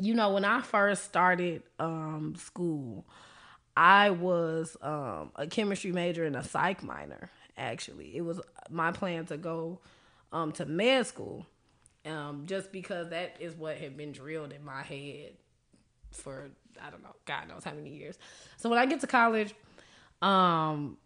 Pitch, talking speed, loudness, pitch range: 170 Hz, 160 wpm, -30 LUFS, 155-200 Hz